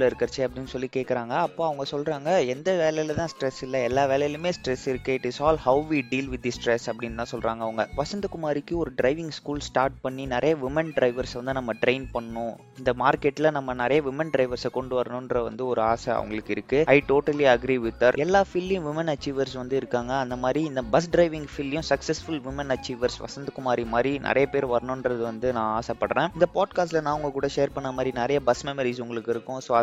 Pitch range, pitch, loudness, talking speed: 125-145 Hz, 130 Hz, -26 LUFS, 190 wpm